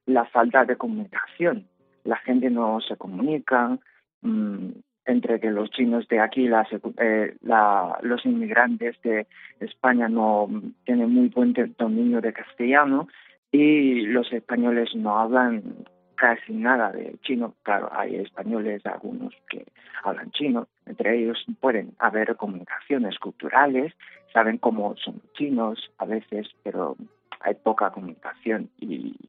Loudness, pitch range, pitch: -24 LUFS, 115-145 Hz, 120 Hz